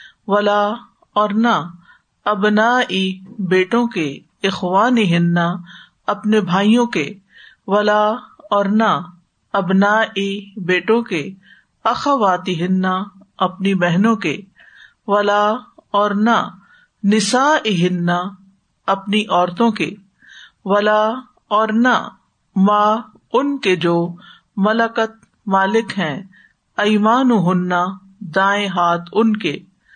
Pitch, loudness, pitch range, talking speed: 205 Hz, -17 LUFS, 185-220 Hz, 65 wpm